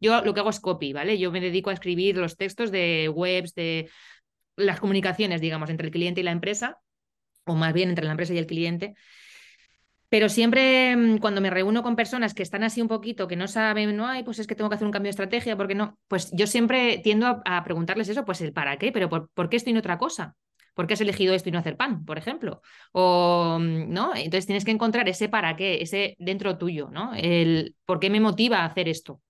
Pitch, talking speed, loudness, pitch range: 195 Hz, 240 wpm, -25 LUFS, 175-220 Hz